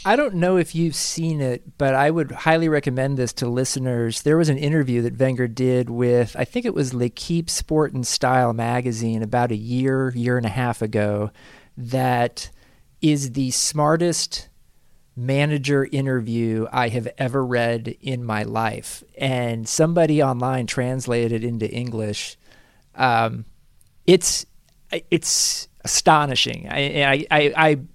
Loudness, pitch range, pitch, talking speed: -21 LUFS, 120-150 Hz, 130 Hz, 150 wpm